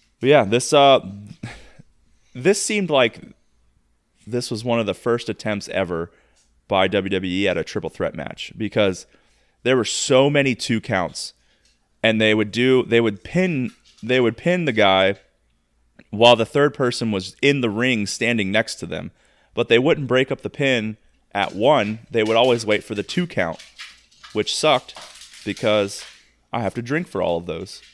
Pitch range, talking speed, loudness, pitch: 100-130 Hz, 175 wpm, -20 LUFS, 115 Hz